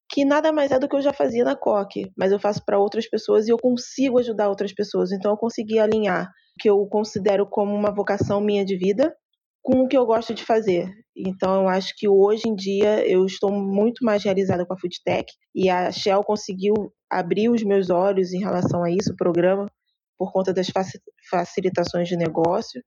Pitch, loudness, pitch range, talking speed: 205 Hz, -22 LUFS, 190-225 Hz, 205 wpm